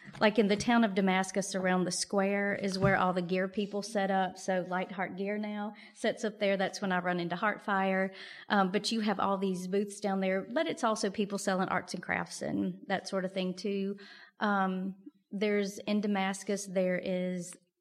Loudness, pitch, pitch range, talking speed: -32 LUFS, 195 Hz, 185-210 Hz, 200 wpm